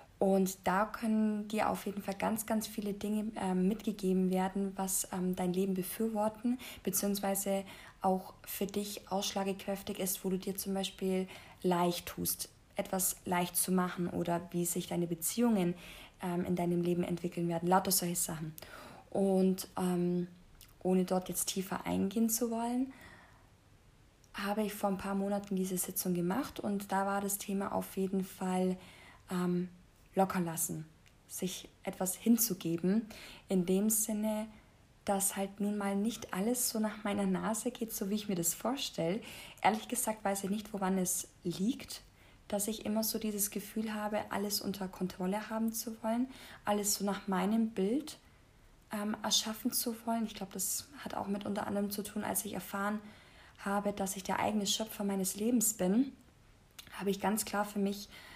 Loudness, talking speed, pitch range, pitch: -35 LUFS, 165 wpm, 185-210 Hz, 195 Hz